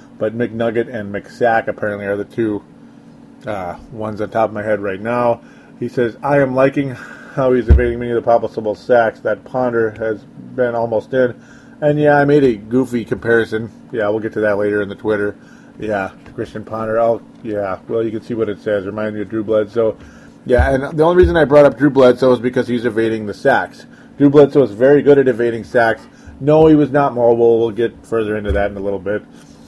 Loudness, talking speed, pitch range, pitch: -16 LUFS, 215 wpm, 105-130 Hz, 115 Hz